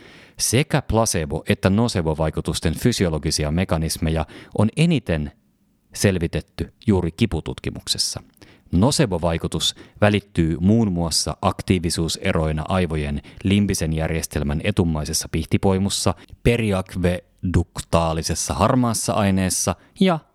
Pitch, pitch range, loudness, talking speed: 90 Hz, 80-100 Hz, -21 LUFS, 75 wpm